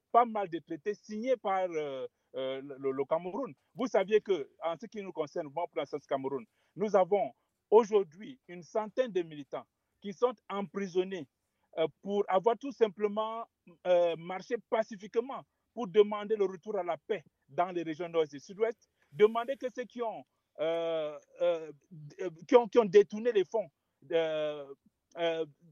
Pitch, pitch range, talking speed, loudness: 185 Hz, 160-220 Hz, 155 wpm, -32 LUFS